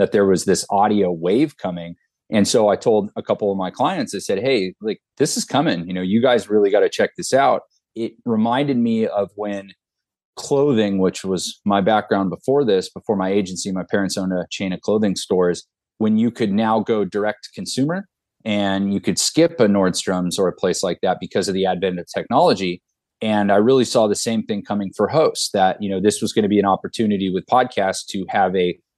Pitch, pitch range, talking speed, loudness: 100 Hz, 95-110 Hz, 220 wpm, -19 LUFS